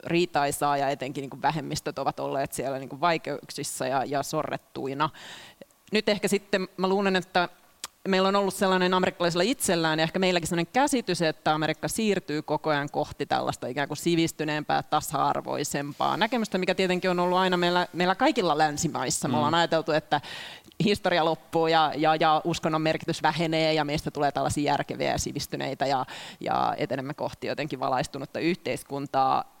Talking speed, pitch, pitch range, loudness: 155 wpm, 160 Hz, 150-185 Hz, -26 LUFS